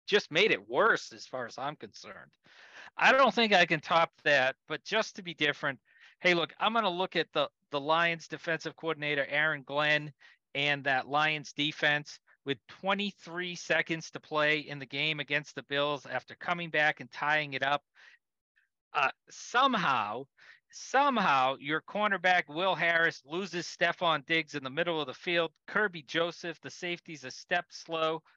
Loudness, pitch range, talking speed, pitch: -30 LUFS, 145-175 Hz, 170 wpm, 160 Hz